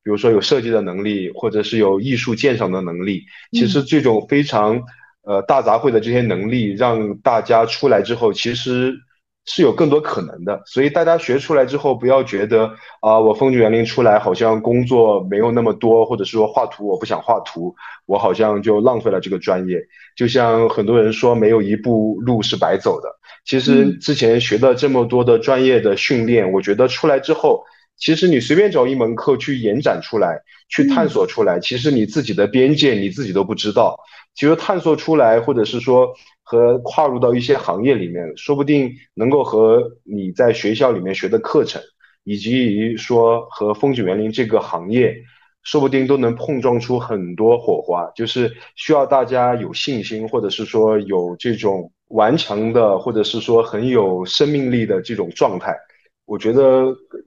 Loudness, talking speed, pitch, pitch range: -16 LUFS, 285 characters per minute, 120 Hz, 110-135 Hz